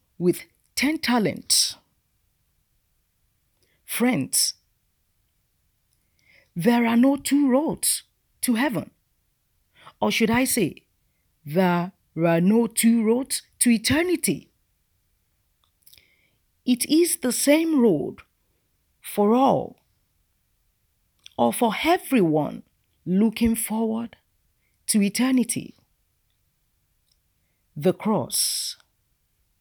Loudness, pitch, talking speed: -22 LUFS, 220 Hz, 75 wpm